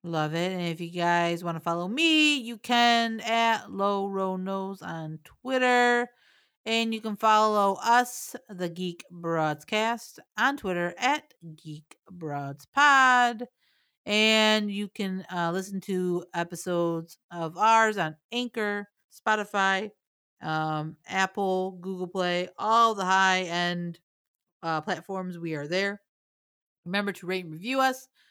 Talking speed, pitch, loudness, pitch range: 130 wpm, 190 Hz, -26 LUFS, 170-225 Hz